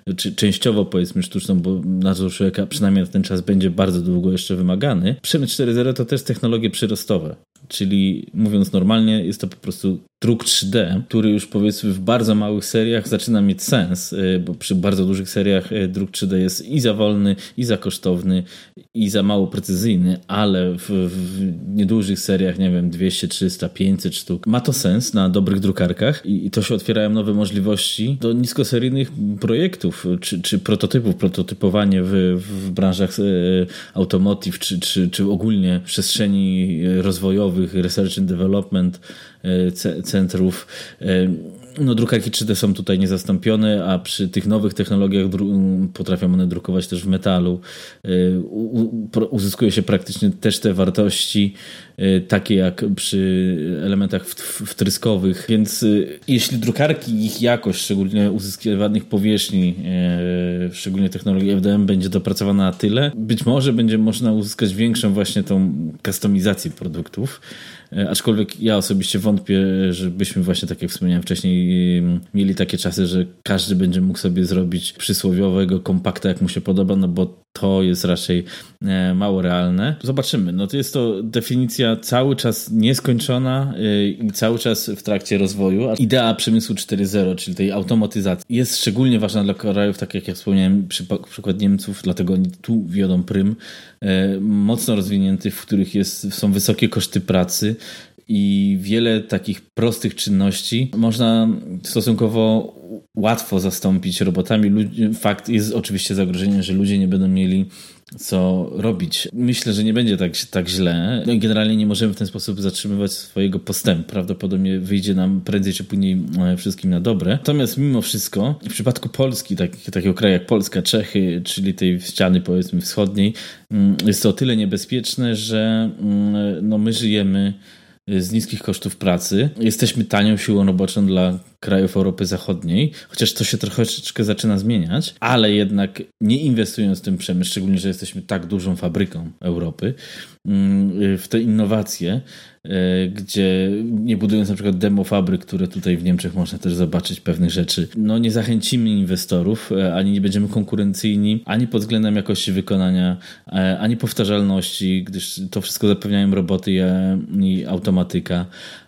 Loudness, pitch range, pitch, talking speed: -19 LUFS, 95-110 Hz, 100 Hz, 145 wpm